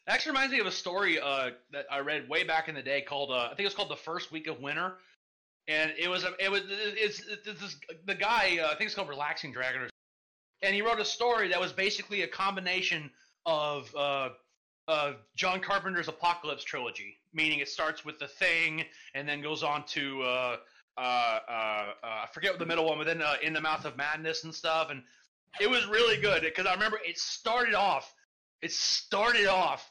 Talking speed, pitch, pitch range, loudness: 215 wpm, 160 Hz, 140-190 Hz, -30 LUFS